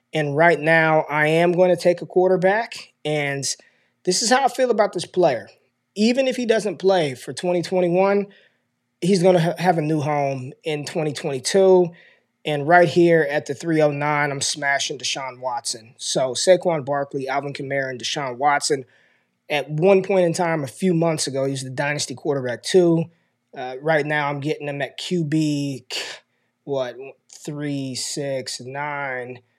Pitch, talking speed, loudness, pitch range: 155 Hz, 160 wpm, -21 LUFS, 140-180 Hz